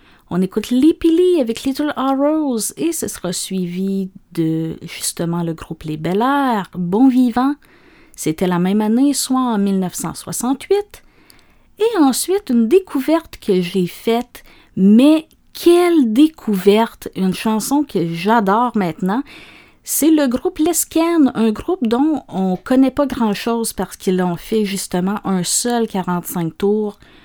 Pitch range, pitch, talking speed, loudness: 190-285 Hz, 230 Hz, 140 wpm, -17 LUFS